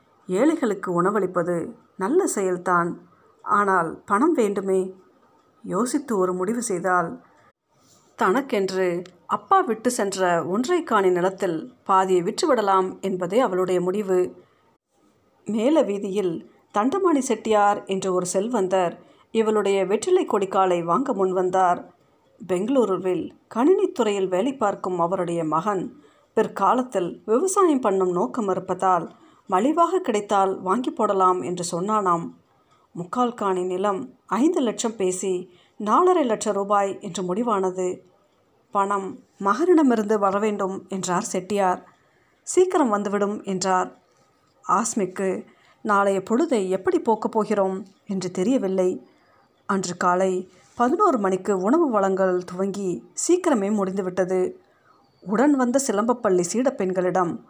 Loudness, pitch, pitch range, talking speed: -23 LUFS, 195 Hz, 185-225 Hz, 95 wpm